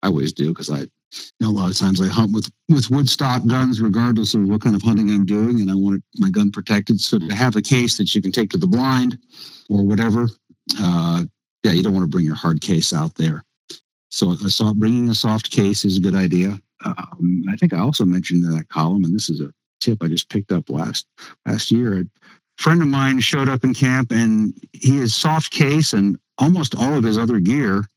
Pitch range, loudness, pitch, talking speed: 95-130 Hz, -18 LUFS, 110 Hz, 225 wpm